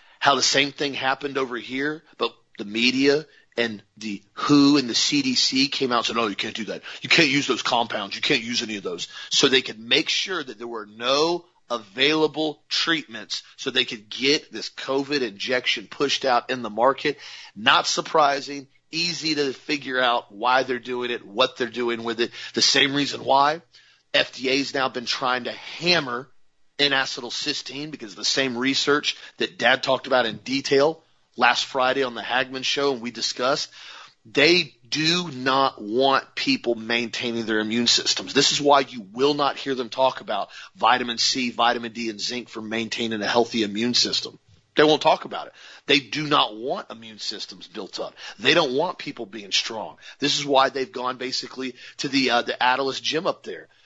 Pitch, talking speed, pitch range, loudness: 130 Hz, 190 wpm, 120-145 Hz, -22 LUFS